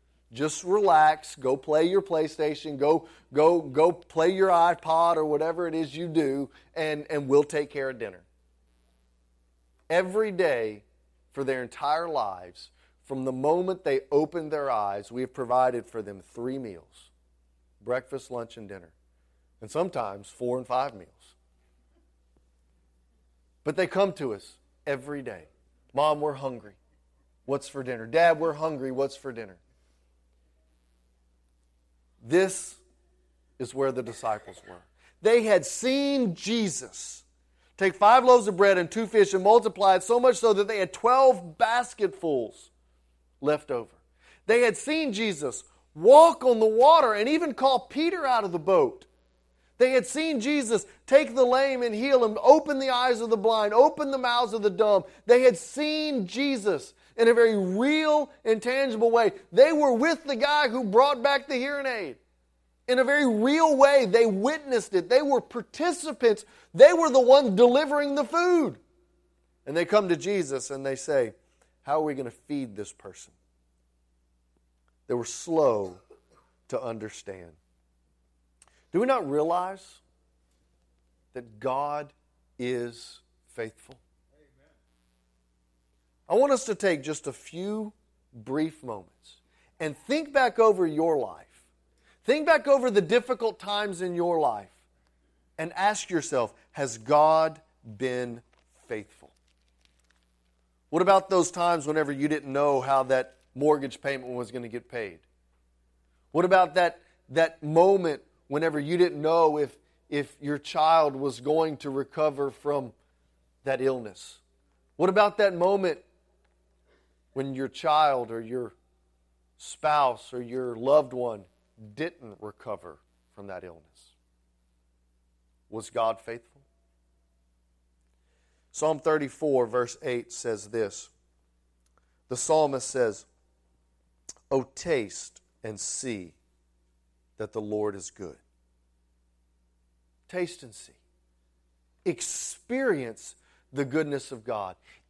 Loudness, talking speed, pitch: -25 LUFS, 135 wpm, 135 Hz